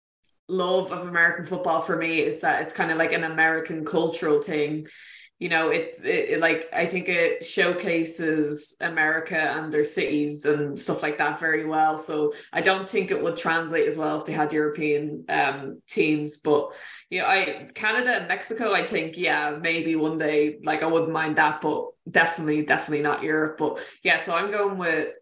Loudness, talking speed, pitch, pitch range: -24 LUFS, 195 wpm, 160 Hz, 150-180 Hz